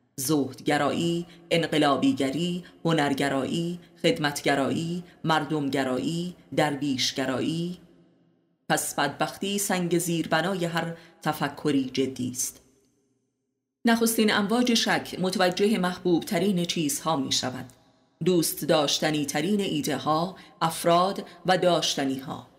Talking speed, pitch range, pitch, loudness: 90 wpm, 135-175 Hz, 160 Hz, -26 LUFS